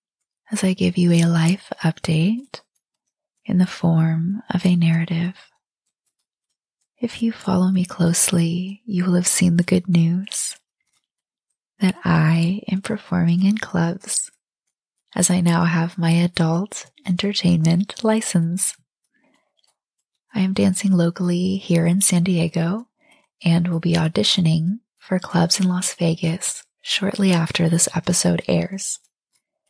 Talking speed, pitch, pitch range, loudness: 125 wpm, 180 Hz, 170-195 Hz, -20 LUFS